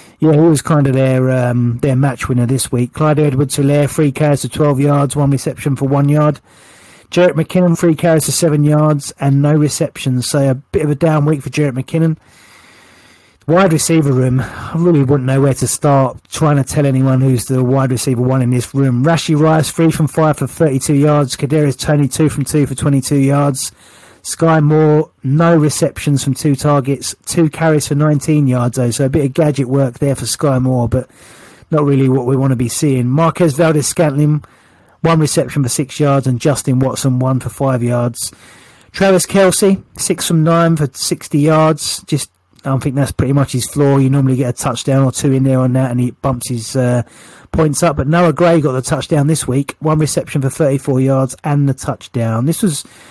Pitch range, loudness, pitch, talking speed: 130-155 Hz, -14 LUFS, 140 Hz, 205 wpm